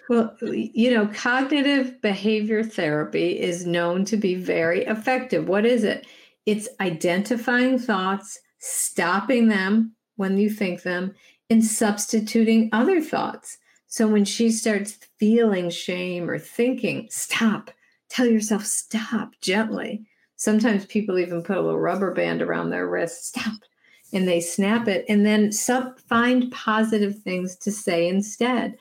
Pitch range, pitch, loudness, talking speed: 190-235 Hz, 215 Hz, -23 LUFS, 135 wpm